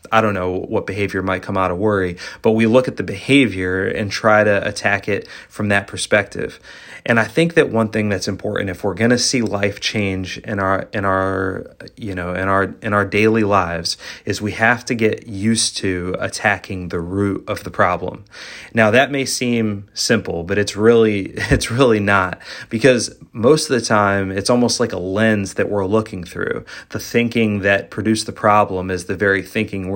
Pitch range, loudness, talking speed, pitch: 95-115 Hz, -18 LUFS, 200 wpm, 105 Hz